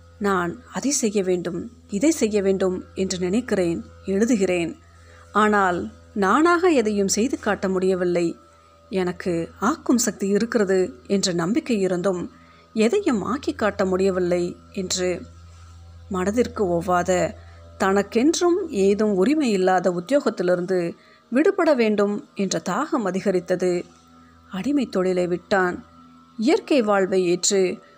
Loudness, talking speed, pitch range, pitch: -22 LUFS, 100 wpm, 175-215 Hz, 190 Hz